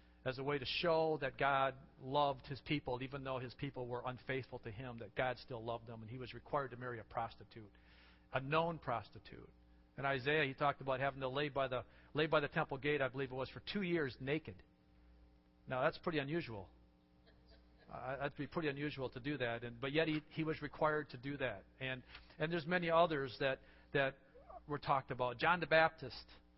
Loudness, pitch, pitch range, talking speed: -40 LUFS, 130 Hz, 115-145 Hz, 210 wpm